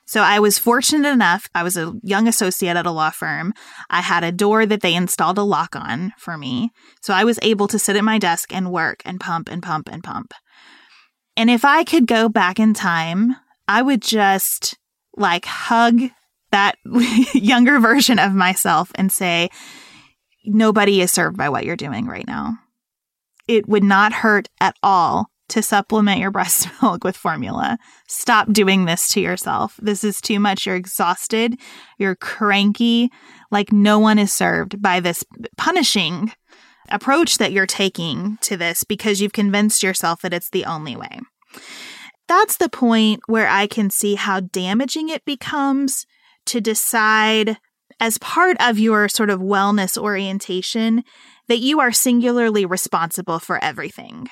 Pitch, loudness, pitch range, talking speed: 210 Hz, -17 LUFS, 190-240 Hz, 165 wpm